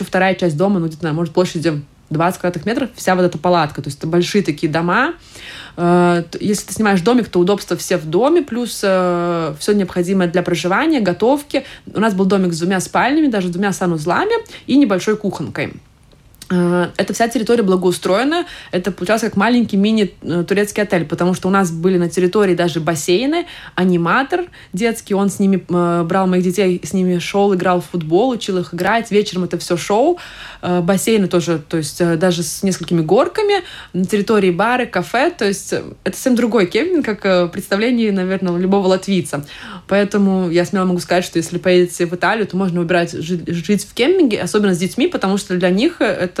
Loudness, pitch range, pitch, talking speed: -16 LUFS, 175-210 Hz, 185 Hz, 175 wpm